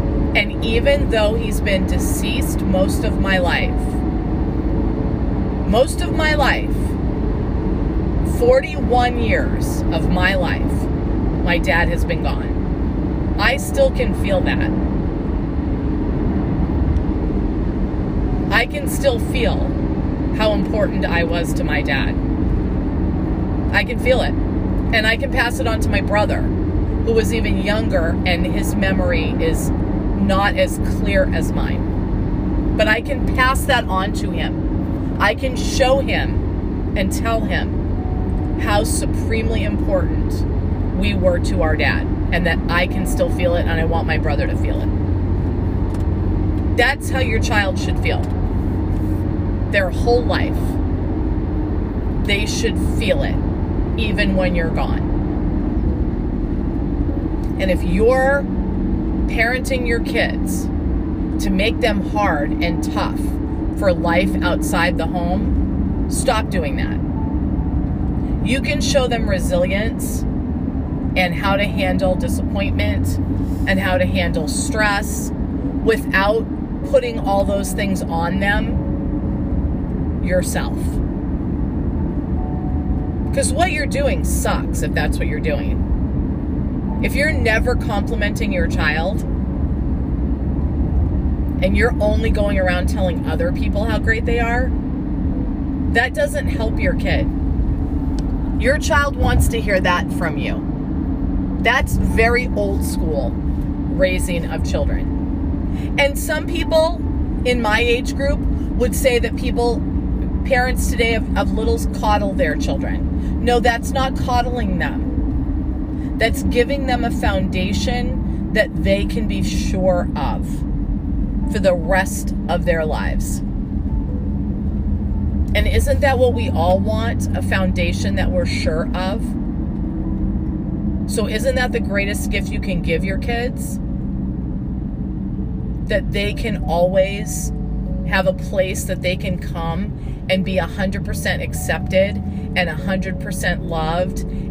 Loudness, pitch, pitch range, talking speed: -19 LUFS, 90 Hz, 80-95 Hz, 125 wpm